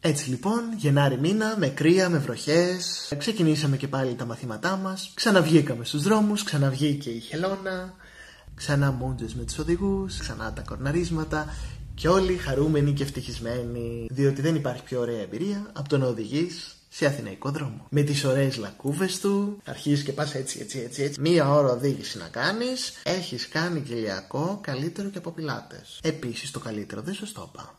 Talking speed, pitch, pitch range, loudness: 165 wpm, 145 Hz, 130-180 Hz, -26 LUFS